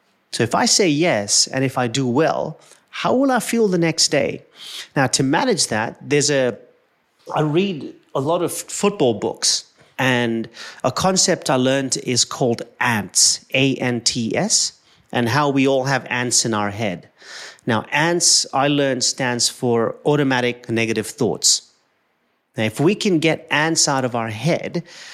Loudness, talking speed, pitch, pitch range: -18 LUFS, 170 wpm, 135 Hz, 120-165 Hz